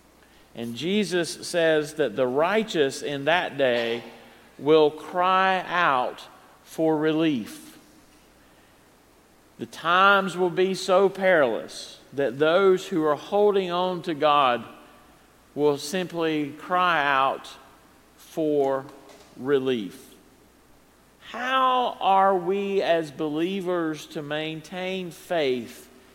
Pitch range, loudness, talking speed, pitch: 145-190 Hz, -24 LUFS, 95 wpm, 165 Hz